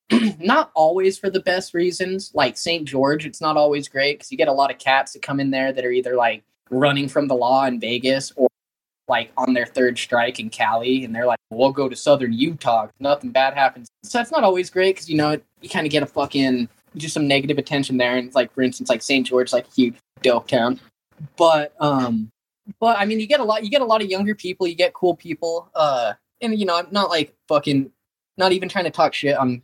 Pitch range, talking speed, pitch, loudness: 130-185 Hz, 245 wpm, 145 Hz, -20 LUFS